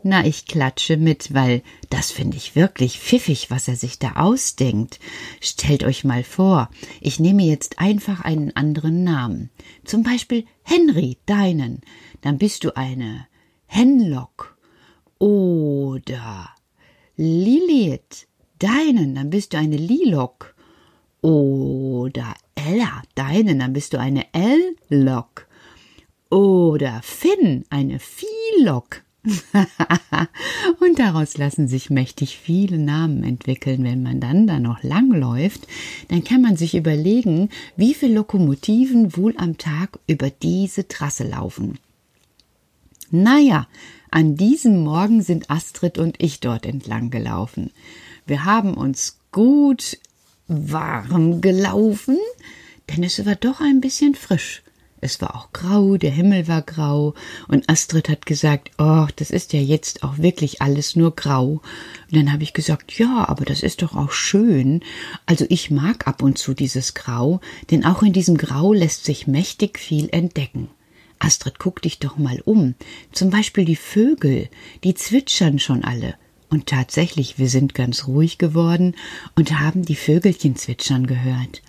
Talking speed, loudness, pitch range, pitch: 140 wpm, -19 LUFS, 140-195 Hz, 160 Hz